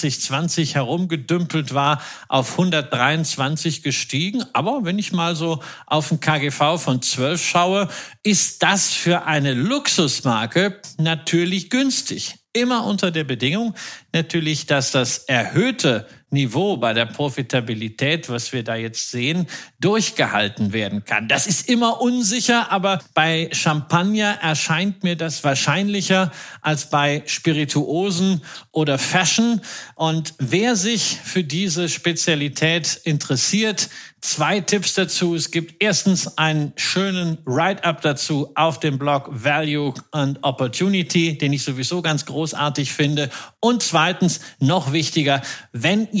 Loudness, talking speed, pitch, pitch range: -19 LUFS, 125 wpm, 160 Hz, 145-185 Hz